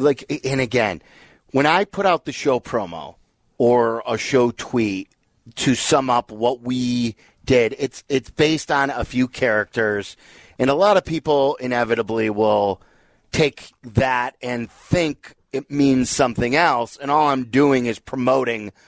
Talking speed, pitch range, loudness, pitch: 155 wpm, 115-140 Hz, -20 LUFS, 125 Hz